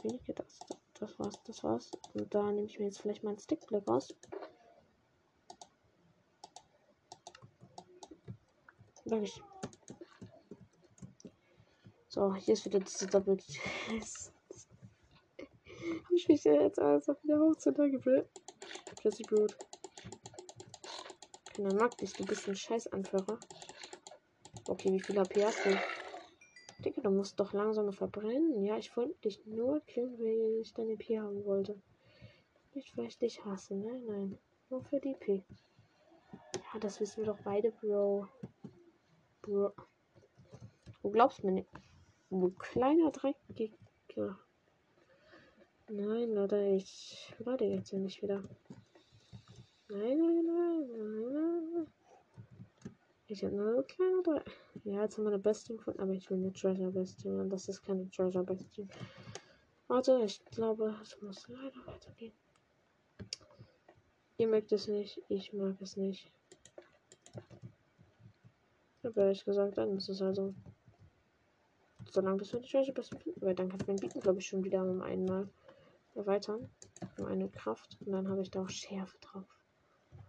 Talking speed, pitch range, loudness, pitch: 140 wpm, 195-235 Hz, -36 LUFS, 205 Hz